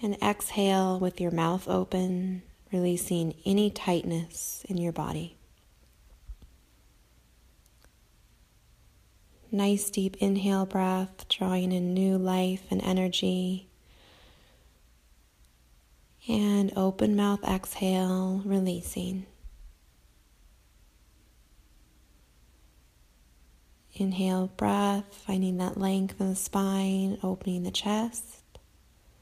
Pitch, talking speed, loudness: 185 Hz, 80 wpm, -29 LUFS